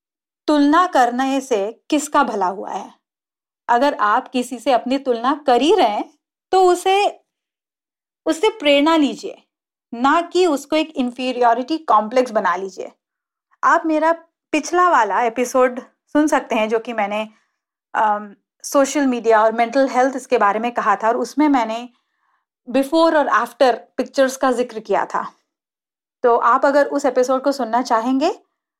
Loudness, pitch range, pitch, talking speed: -18 LUFS, 240-310 Hz, 270 Hz, 150 wpm